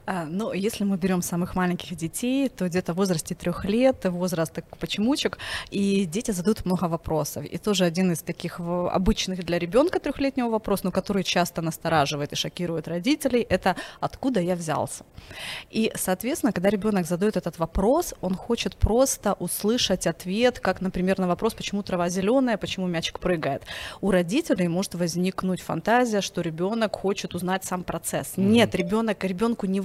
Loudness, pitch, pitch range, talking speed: -25 LUFS, 190 Hz, 175-215 Hz, 160 wpm